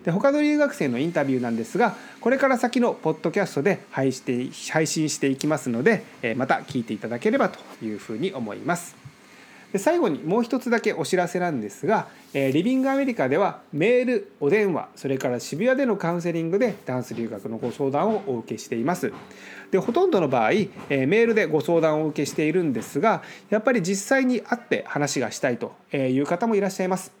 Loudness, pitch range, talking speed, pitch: -24 LUFS, 140-235 Hz, 410 characters per minute, 180 Hz